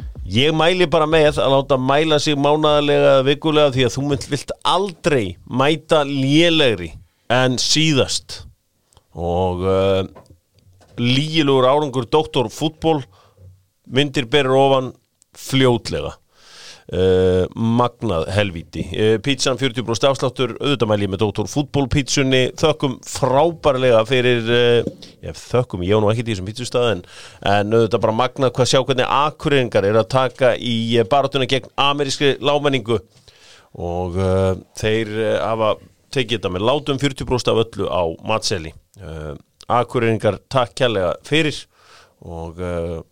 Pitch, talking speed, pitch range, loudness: 125 Hz, 130 wpm, 100-140 Hz, -18 LUFS